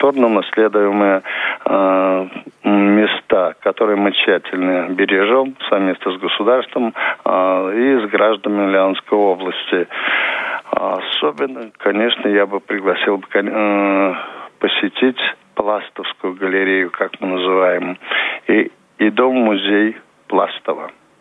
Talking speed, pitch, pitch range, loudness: 90 wpm, 100 Hz, 95-105 Hz, -16 LUFS